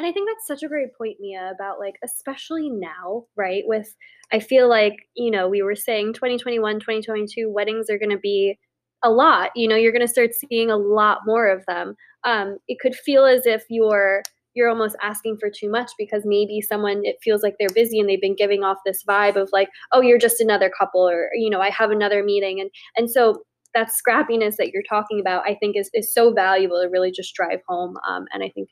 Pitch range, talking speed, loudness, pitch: 200-230 Hz, 230 wpm, -20 LUFS, 210 Hz